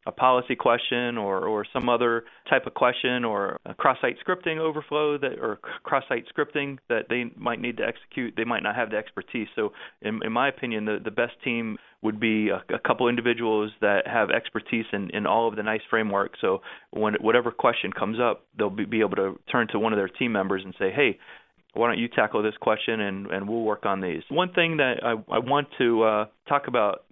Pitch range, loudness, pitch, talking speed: 105-125 Hz, -26 LUFS, 115 Hz, 220 wpm